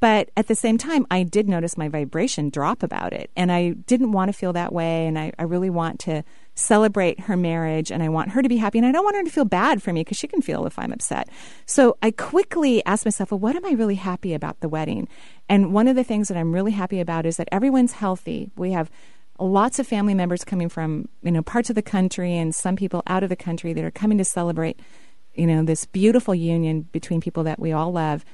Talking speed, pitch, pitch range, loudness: 250 wpm, 185 Hz, 165-220 Hz, -22 LUFS